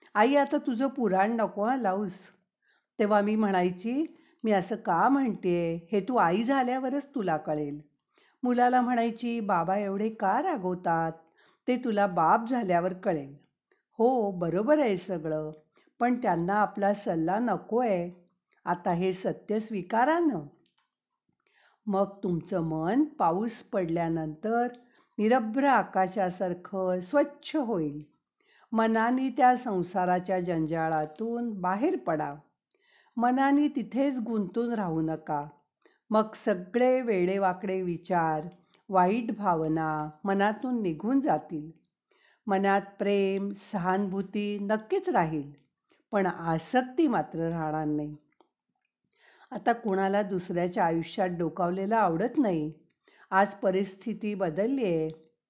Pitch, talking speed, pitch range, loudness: 195 Hz, 105 wpm, 175-235 Hz, -28 LUFS